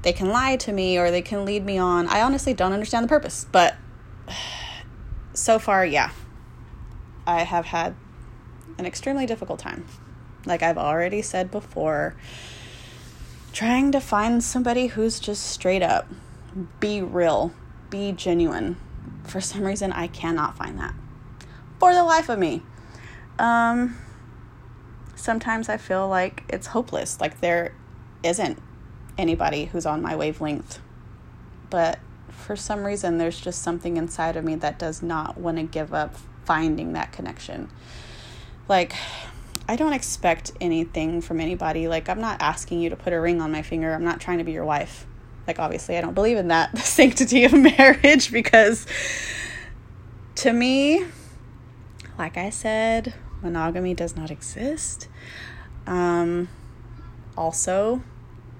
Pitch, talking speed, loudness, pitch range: 175 Hz, 145 wpm, -22 LUFS, 155-220 Hz